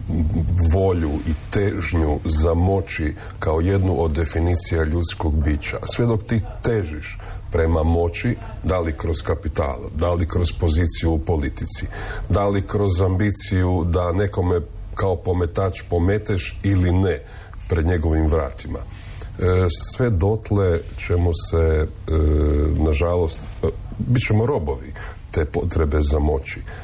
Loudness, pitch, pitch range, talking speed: -21 LUFS, 90 Hz, 80-100 Hz, 120 wpm